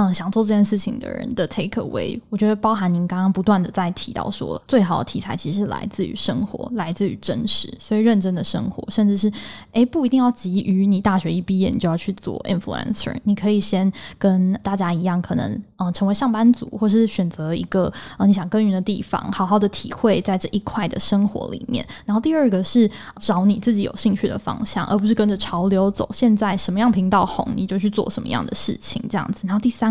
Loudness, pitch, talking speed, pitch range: -20 LUFS, 205 Hz, 370 characters per minute, 190-220 Hz